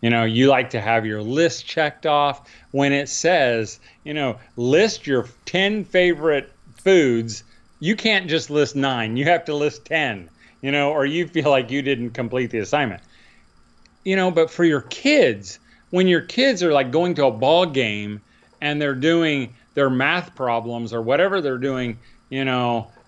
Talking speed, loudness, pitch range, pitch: 180 wpm, -20 LUFS, 120-165 Hz, 140 Hz